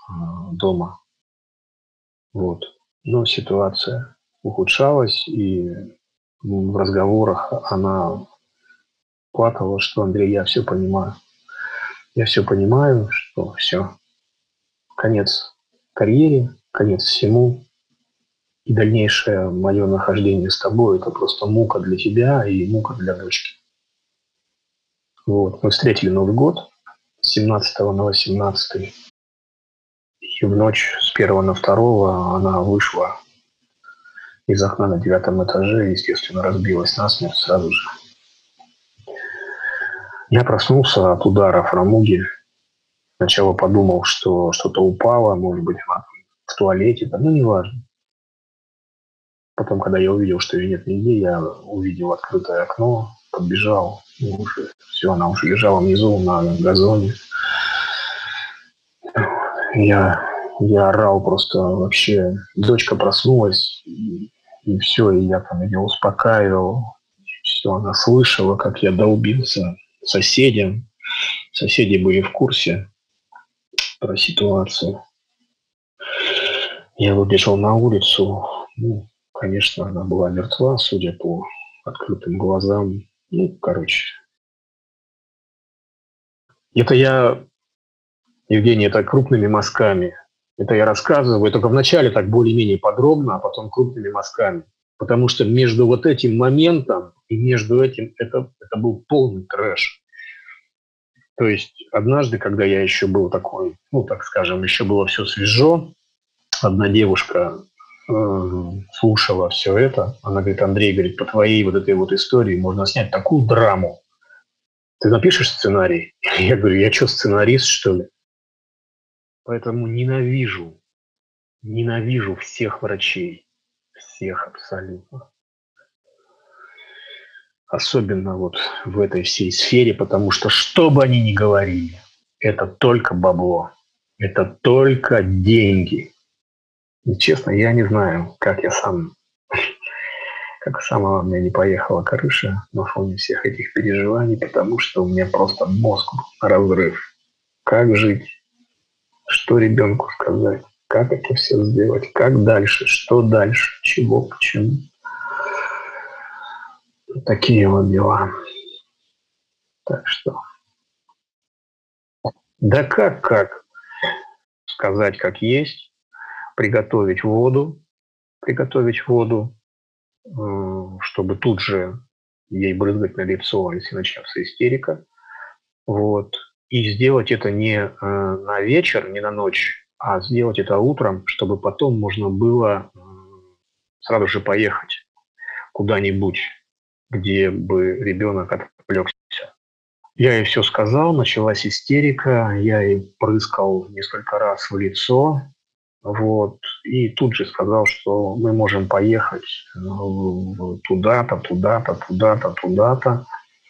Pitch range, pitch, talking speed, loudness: 95-130 Hz, 110 Hz, 110 wpm, -17 LUFS